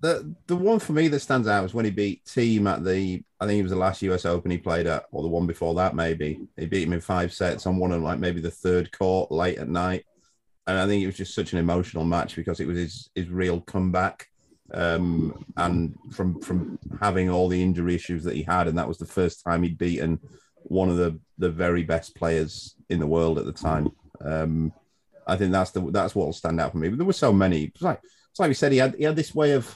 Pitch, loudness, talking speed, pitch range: 90 Hz, -25 LUFS, 260 wpm, 85-95 Hz